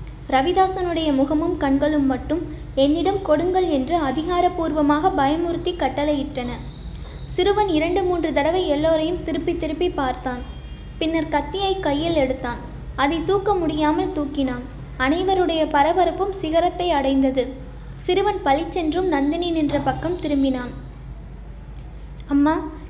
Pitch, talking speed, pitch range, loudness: 315 Hz, 95 wpm, 285-355 Hz, -21 LUFS